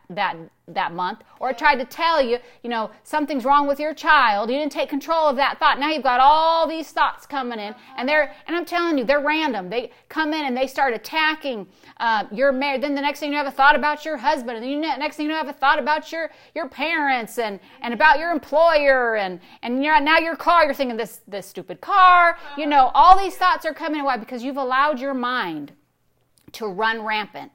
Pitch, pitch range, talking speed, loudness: 290 Hz, 255-310 Hz, 225 wpm, -20 LUFS